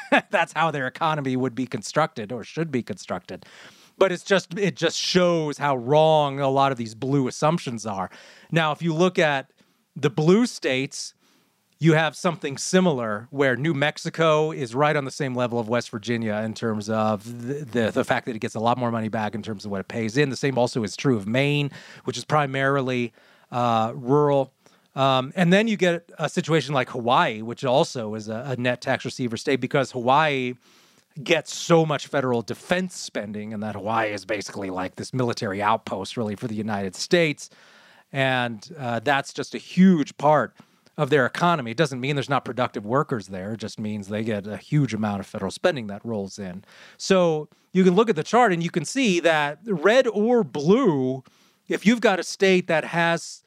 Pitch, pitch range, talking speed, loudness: 135 Hz, 120-165 Hz, 200 wpm, -23 LUFS